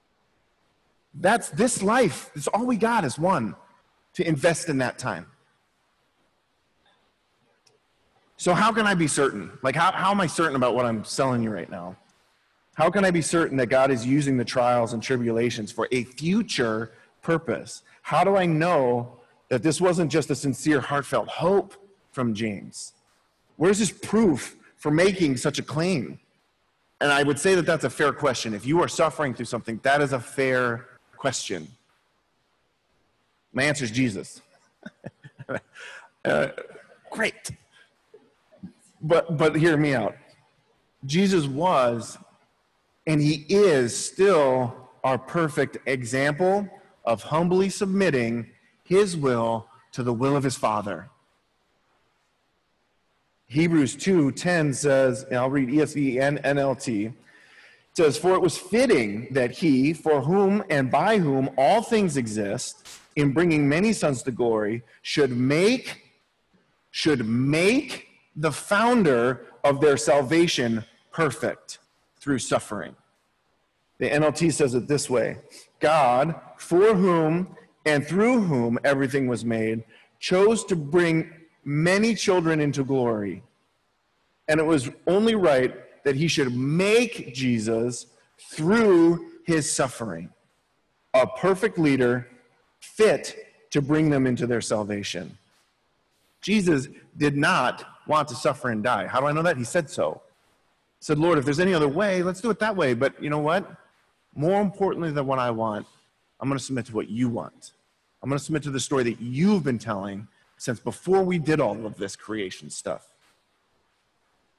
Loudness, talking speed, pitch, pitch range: -23 LUFS, 145 wpm, 145 Hz, 125-175 Hz